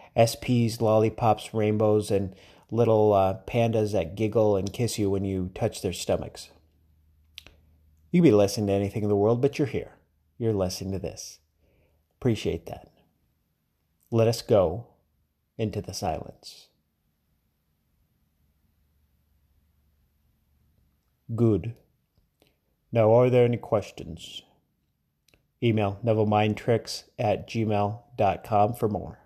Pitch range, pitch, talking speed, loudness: 80-110 Hz, 100 Hz, 105 wpm, -25 LUFS